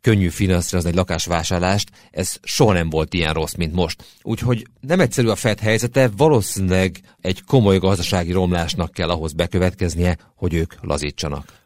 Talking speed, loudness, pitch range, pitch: 150 wpm, -20 LUFS, 85-110 Hz, 90 Hz